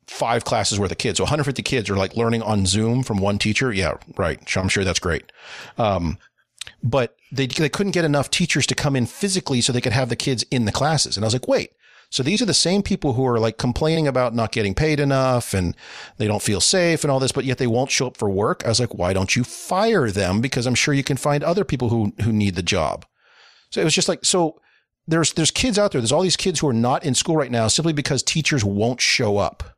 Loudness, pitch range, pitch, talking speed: -20 LUFS, 110-150 Hz, 130 Hz, 260 wpm